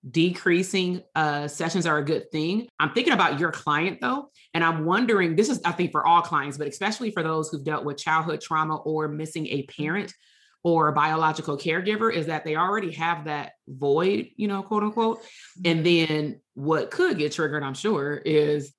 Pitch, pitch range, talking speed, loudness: 165 Hz, 150-190 Hz, 190 wpm, -25 LUFS